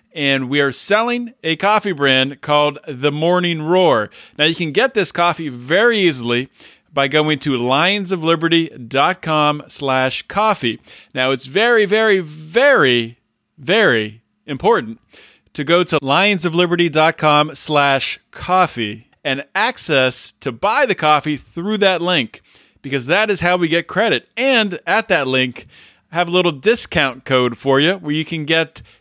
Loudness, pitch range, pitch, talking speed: -16 LUFS, 135-180 Hz, 155 Hz, 145 wpm